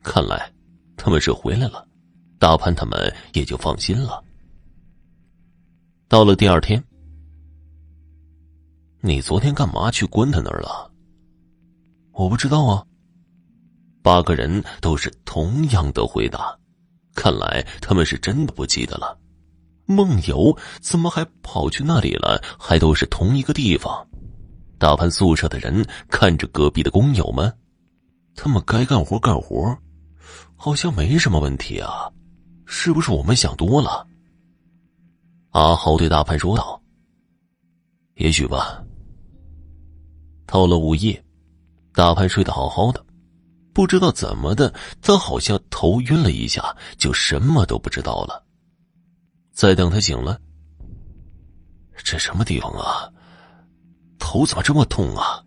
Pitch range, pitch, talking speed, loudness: 80-125 Hz, 85 Hz, 190 characters per minute, -19 LUFS